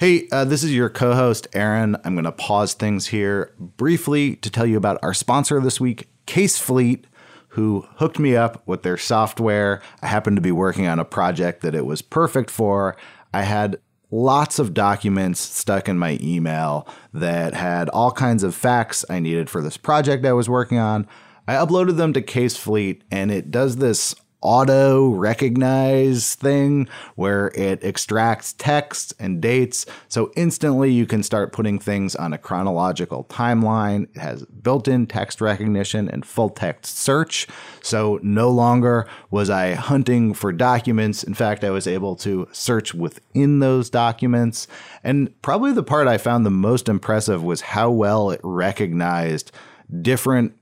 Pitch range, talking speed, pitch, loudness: 100-130 Hz, 165 wpm, 110 Hz, -20 LUFS